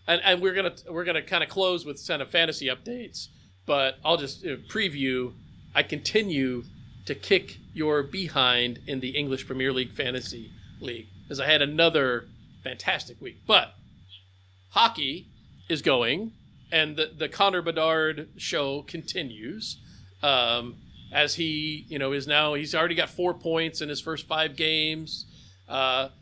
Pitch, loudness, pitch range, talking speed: 145 Hz, -26 LUFS, 130-165 Hz, 160 wpm